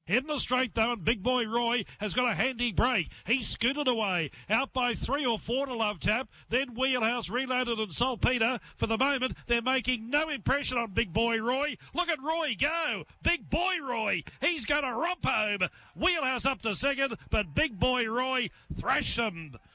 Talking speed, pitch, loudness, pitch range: 190 wpm, 245 Hz, -29 LUFS, 225-265 Hz